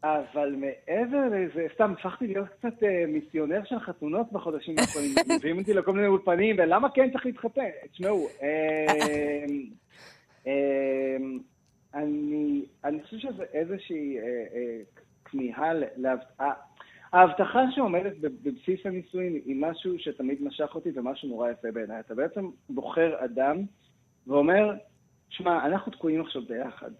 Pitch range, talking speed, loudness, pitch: 140-195 Hz, 110 wpm, -28 LUFS, 160 Hz